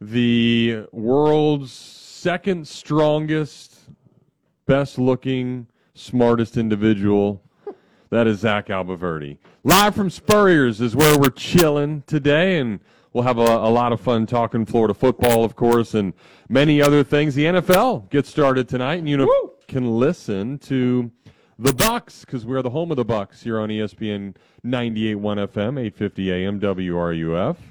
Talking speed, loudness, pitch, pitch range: 135 wpm, -19 LUFS, 125 Hz, 110-145 Hz